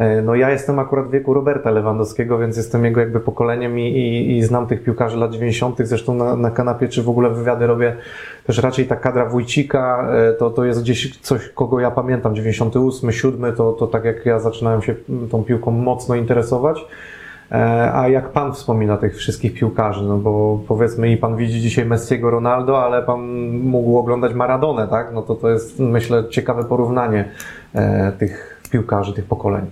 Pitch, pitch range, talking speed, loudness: 120 Hz, 115-125 Hz, 180 wpm, -18 LUFS